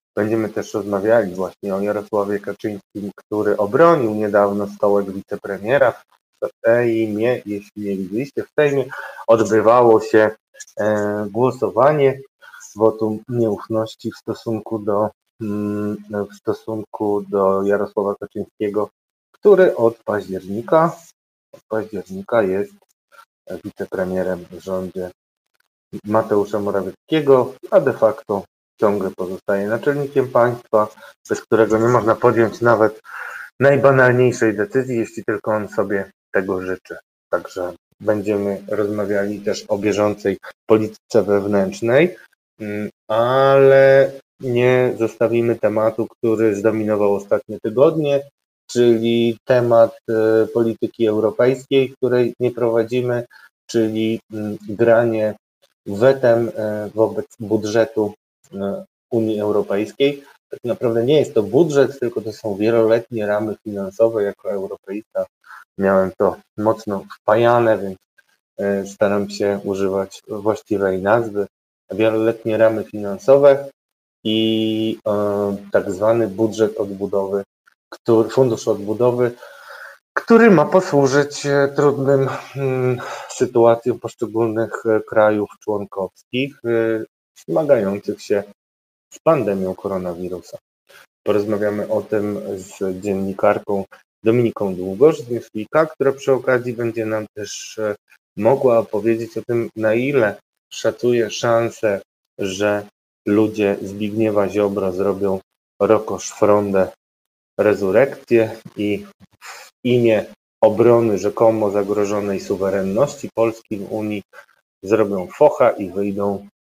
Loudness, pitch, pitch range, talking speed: -18 LUFS, 110 Hz, 100-120 Hz, 95 wpm